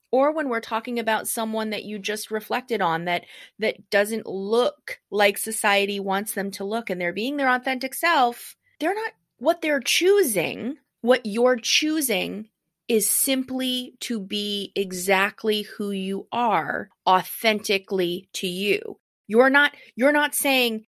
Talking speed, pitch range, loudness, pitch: 145 wpm, 200-260 Hz, -23 LUFS, 225 Hz